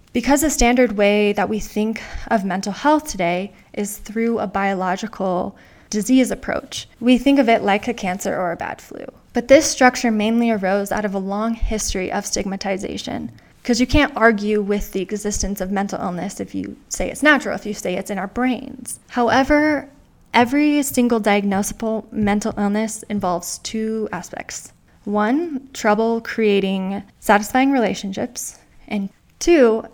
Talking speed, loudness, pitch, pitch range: 155 wpm, -19 LUFS, 215 Hz, 200-245 Hz